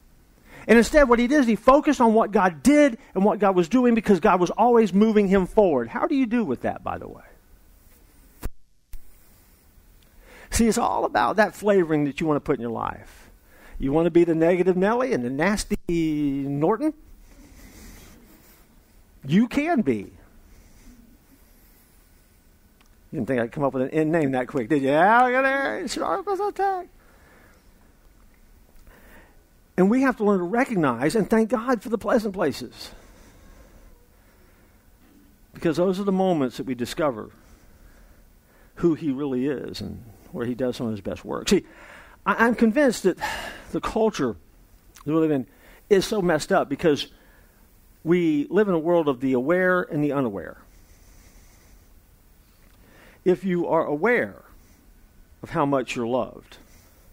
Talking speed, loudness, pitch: 155 wpm, -22 LUFS, 155 Hz